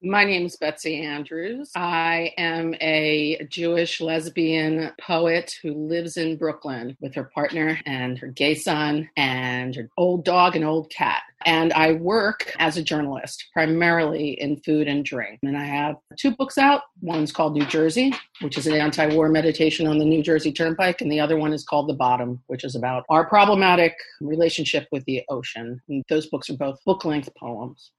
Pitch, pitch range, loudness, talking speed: 155 Hz, 145-165 Hz, -22 LUFS, 180 wpm